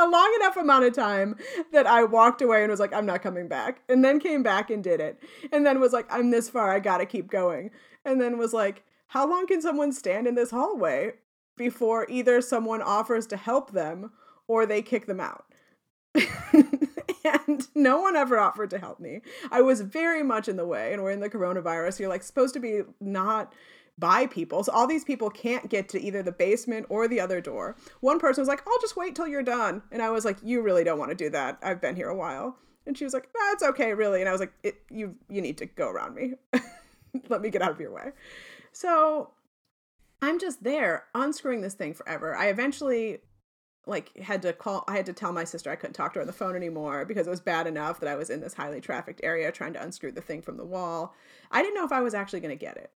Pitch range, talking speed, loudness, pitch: 200-280 Hz, 245 wpm, -26 LUFS, 235 Hz